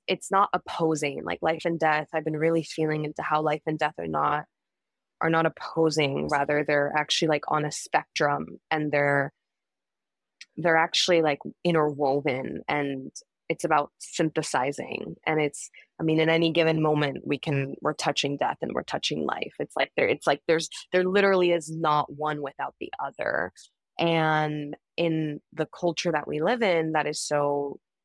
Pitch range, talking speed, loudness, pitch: 150-165 Hz, 170 wpm, -26 LUFS, 155 Hz